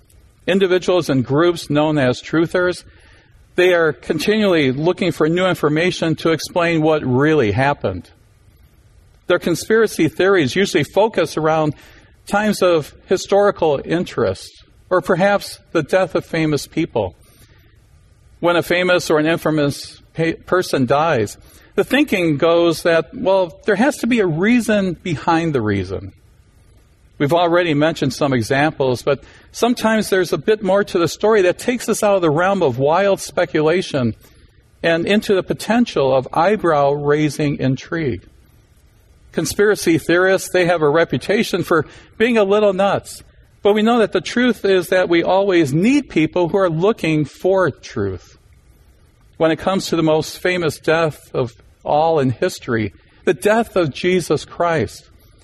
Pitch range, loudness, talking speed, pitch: 130-190 Hz, -17 LUFS, 145 wpm, 165 Hz